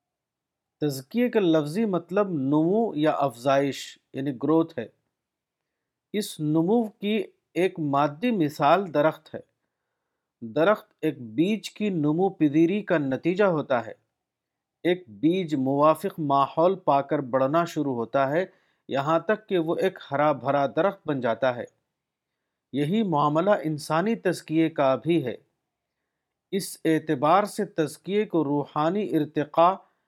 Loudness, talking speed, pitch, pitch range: -25 LUFS, 125 wpm, 160 Hz, 145-190 Hz